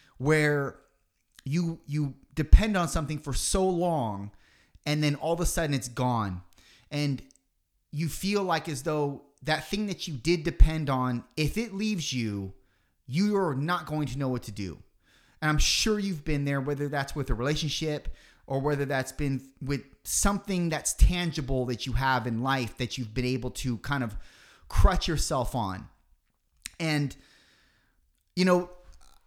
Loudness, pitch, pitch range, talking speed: -29 LUFS, 140 Hz, 125-160 Hz, 160 wpm